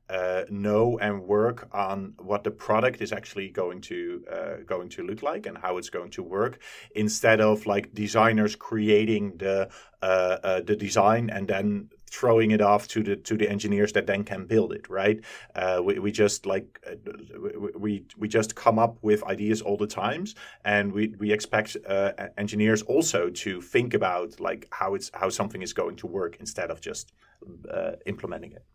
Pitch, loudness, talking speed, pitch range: 105 Hz, -26 LUFS, 190 wpm, 100-110 Hz